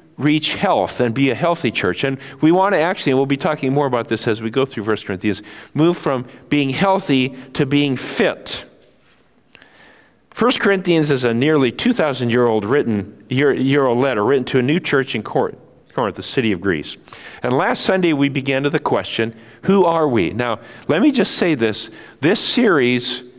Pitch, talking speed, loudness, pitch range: 135 Hz, 190 wpm, -18 LUFS, 120-150 Hz